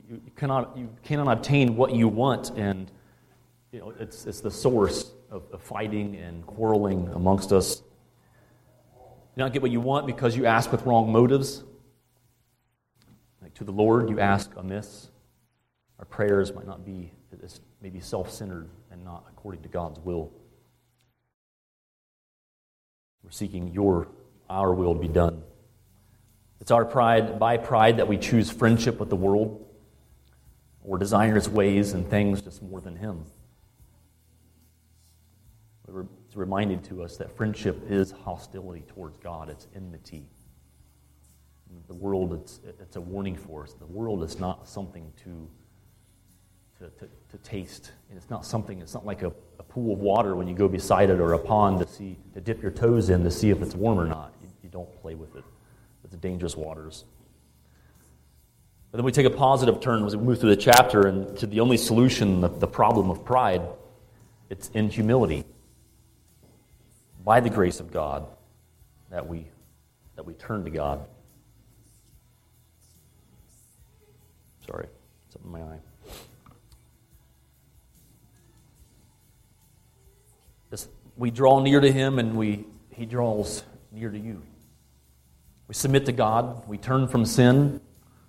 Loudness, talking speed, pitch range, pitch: -24 LUFS, 150 wpm, 90-115 Hz, 105 Hz